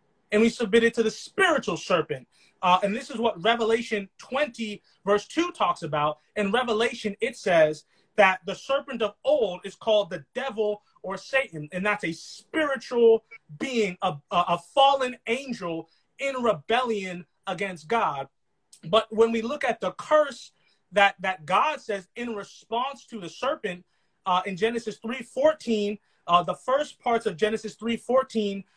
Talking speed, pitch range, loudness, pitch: 160 wpm, 190-235 Hz, -26 LUFS, 215 Hz